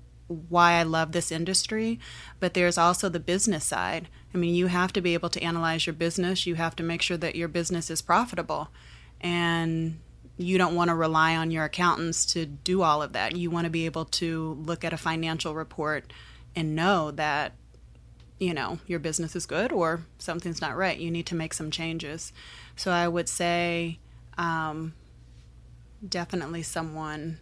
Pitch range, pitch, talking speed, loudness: 160-175 Hz, 165 Hz, 180 wpm, -27 LUFS